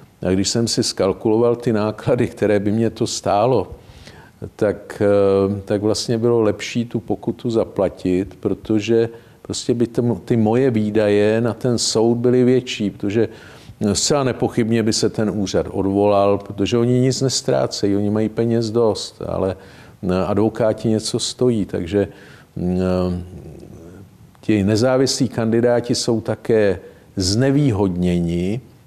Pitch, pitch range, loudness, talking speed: 110 Hz, 100-120 Hz, -19 LUFS, 125 wpm